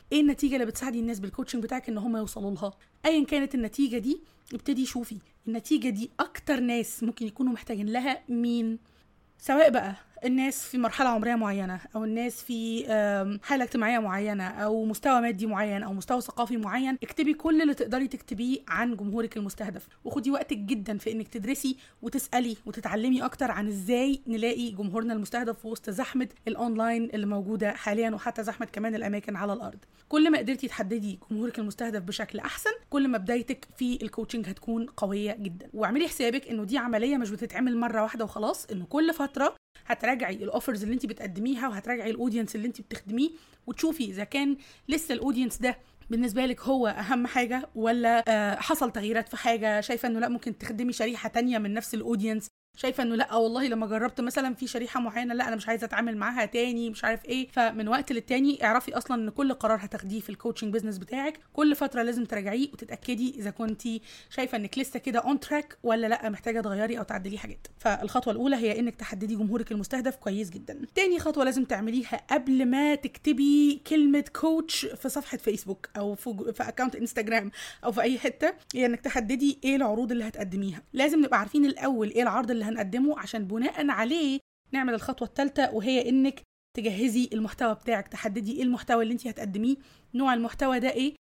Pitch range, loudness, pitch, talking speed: 220-260 Hz, -29 LUFS, 235 Hz, 175 wpm